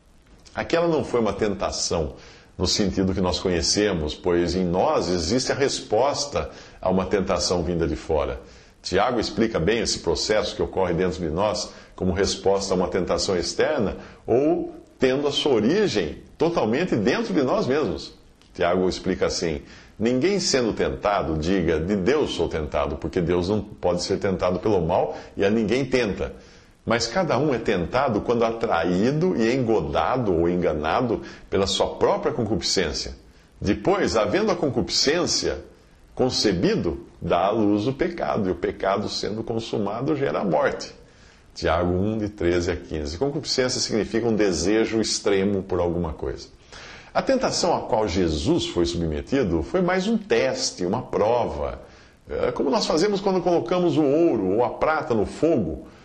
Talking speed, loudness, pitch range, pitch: 155 wpm, -23 LUFS, 90-130 Hz, 100 Hz